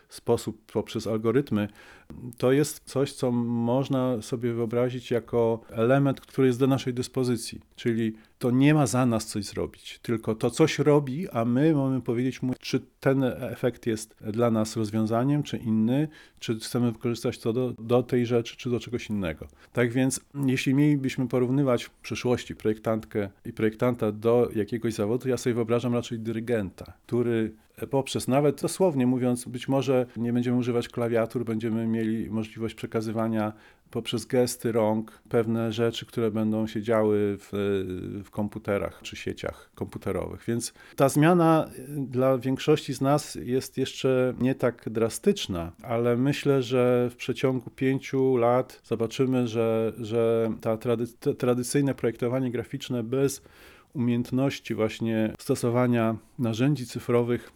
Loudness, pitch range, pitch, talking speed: -27 LUFS, 115-130 Hz, 120 Hz, 140 wpm